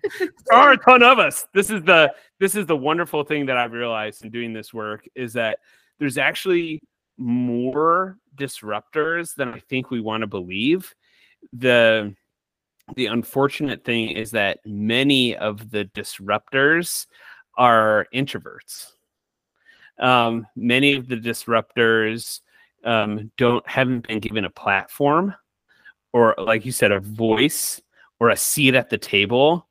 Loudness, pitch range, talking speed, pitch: -19 LUFS, 110-150 Hz, 140 wpm, 125 Hz